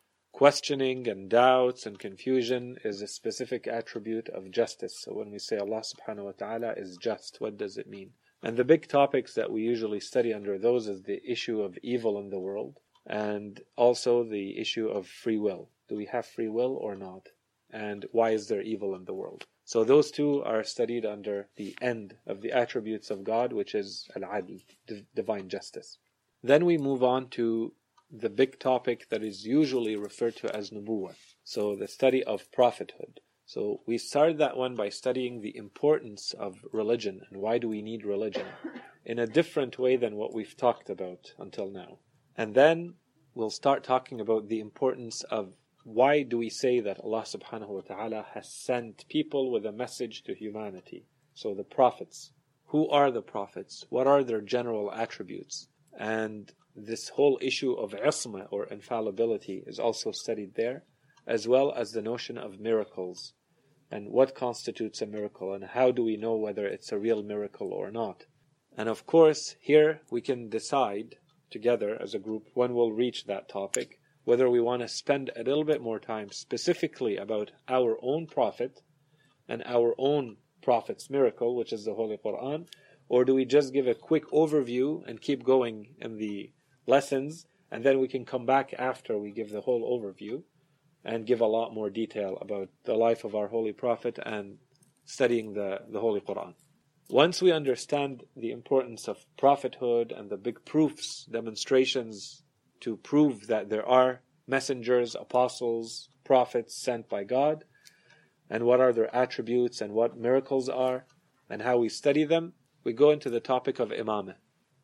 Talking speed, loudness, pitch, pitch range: 175 wpm, -29 LUFS, 120 Hz, 110-135 Hz